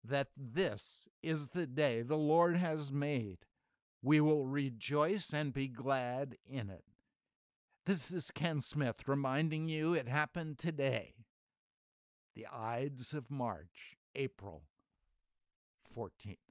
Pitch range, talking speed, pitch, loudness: 120-155 Hz, 115 wpm, 140 Hz, -36 LUFS